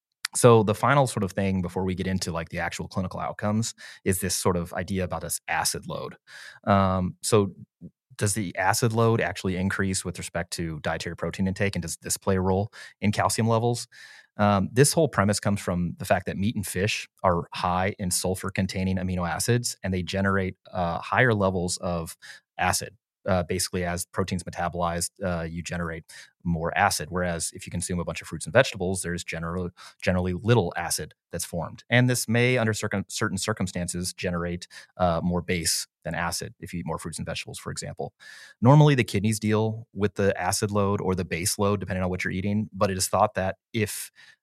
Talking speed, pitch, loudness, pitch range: 195 wpm, 95 Hz, -26 LUFS, 90-105 Hz